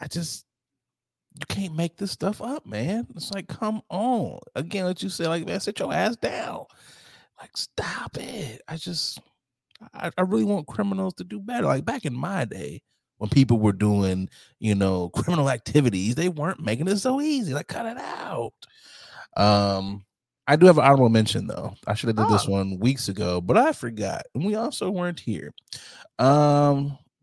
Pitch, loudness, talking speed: 140 Hz, -24 LUFS, 185 wpm